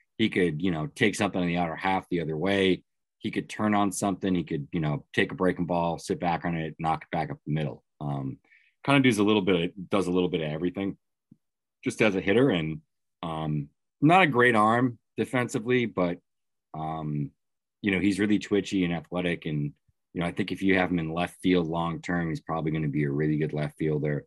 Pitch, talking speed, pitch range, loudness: 90 Hz, 230 wpm, 80-100 Hz, -27 LUFS